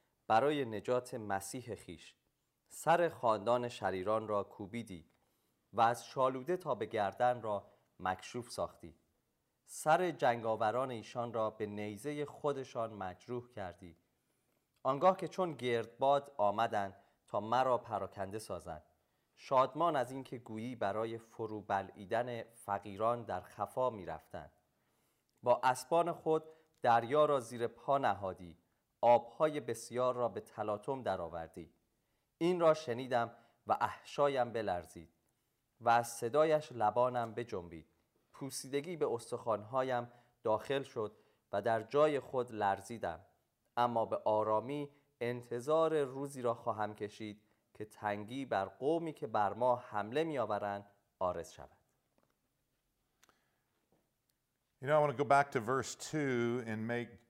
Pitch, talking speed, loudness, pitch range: 120 Hz, 105 wpm, -36 LUFS, 105-135 Hz